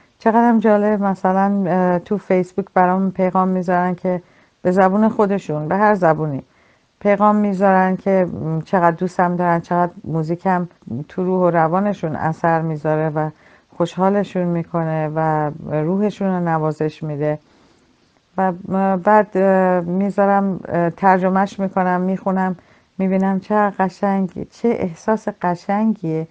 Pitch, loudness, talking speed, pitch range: 185 Hz, -18 LUFS, 110 wpm, 170-195 Hz